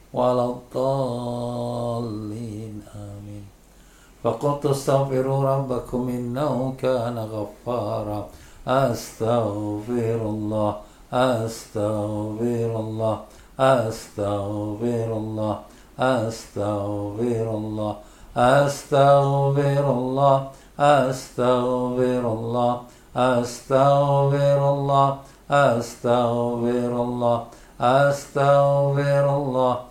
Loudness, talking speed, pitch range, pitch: -22 LUFS, 55 wpm, 110-135 Hz, 120 Hz